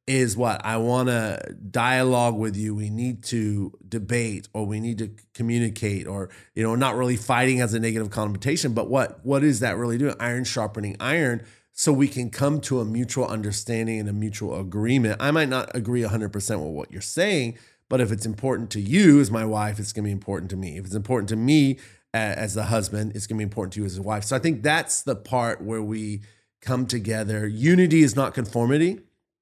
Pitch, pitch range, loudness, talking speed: 115 Hz, 105-125 Hz, -24 LUFS, 215 wpm